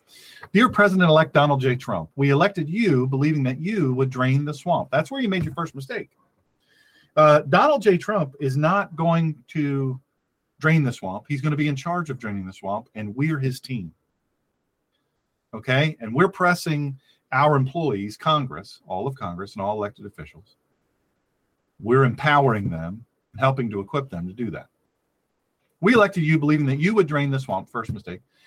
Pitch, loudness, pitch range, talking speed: 140 Hz, -22 LUFS, 125-160 Hz, 180 wpm